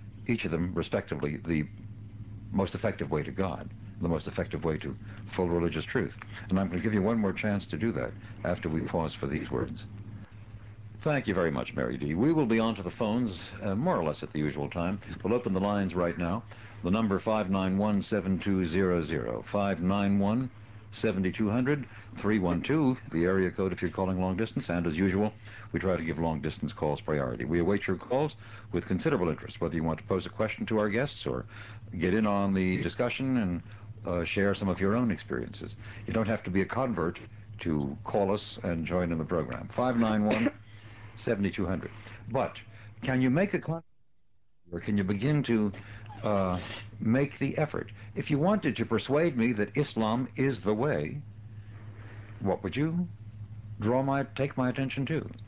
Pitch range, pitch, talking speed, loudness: 95-110 Hz, 105 Hz, 180 wpm, -30 LUFS